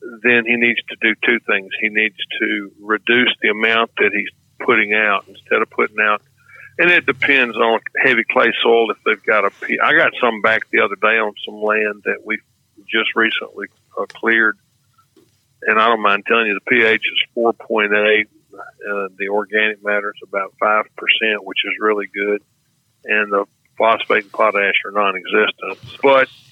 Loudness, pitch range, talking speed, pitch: -16 LUFS, 105-120 Hz, 185 wpm, 110 Hz